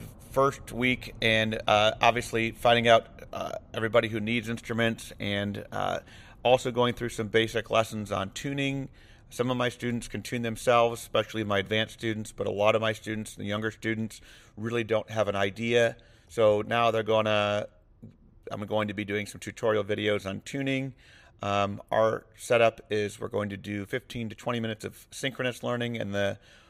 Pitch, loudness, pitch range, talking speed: 110 Hz, -28 LUFS, 105-120 Hz, 175 wpm